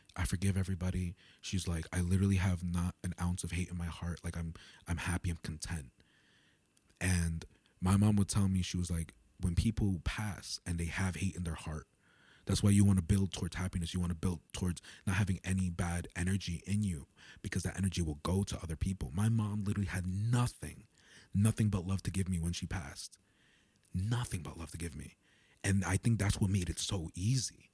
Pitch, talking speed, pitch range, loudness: 90 Hz, 210 wpm, 85-100 Hz, -35 LUFS